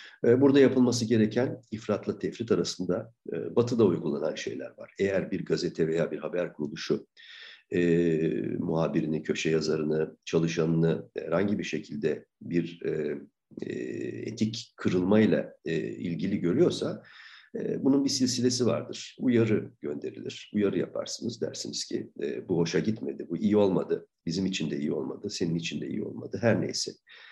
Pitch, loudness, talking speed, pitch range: 95 Hz, -29 LUFS, 135 wpm, 80-120 Hz